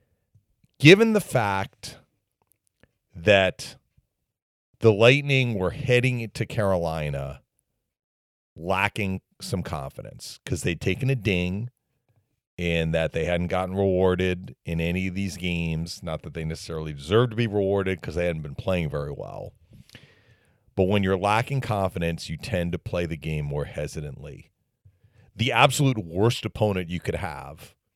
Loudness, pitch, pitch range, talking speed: -24 LUFS, 95 Hz, 85-115 Hz, 135 wpm